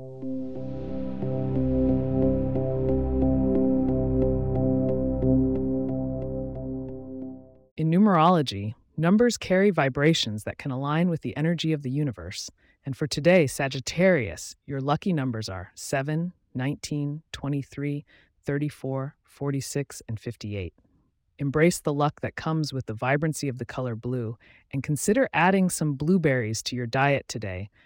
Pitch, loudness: 130 Hz, -26 LUFS